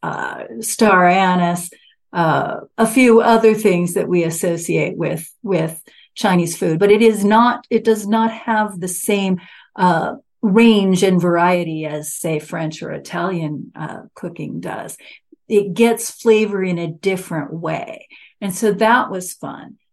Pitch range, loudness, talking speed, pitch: 175-225 Hz, -17 LUFS, 150 wpm, 195 Hz